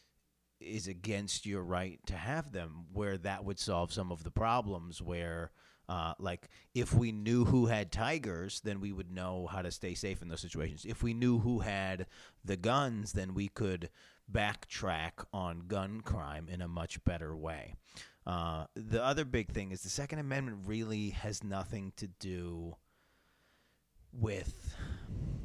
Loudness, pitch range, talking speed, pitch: -37 LUFS, 85-110 Hz, 165 wpm, 95 Hz